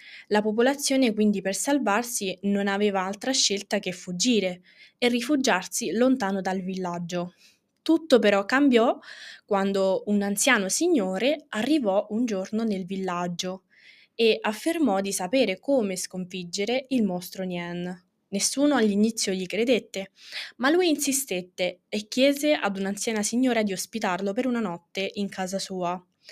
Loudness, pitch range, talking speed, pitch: -25 LUFS, 190-245 Hz, 130 wpm, 200 Hz